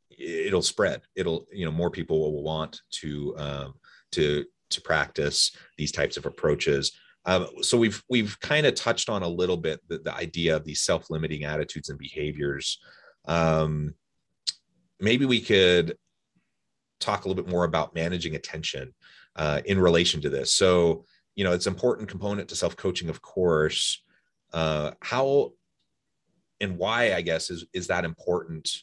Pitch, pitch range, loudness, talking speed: 85 Hz, 75-95 Hz, -26 LUFS, 160 wpm